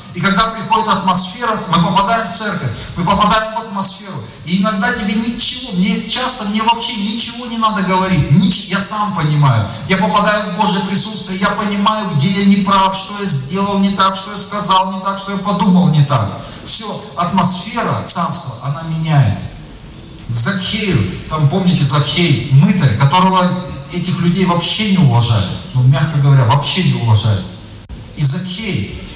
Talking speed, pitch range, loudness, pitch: 160 wpm, 150-205 Hz, -11 LUFS, 185 Hz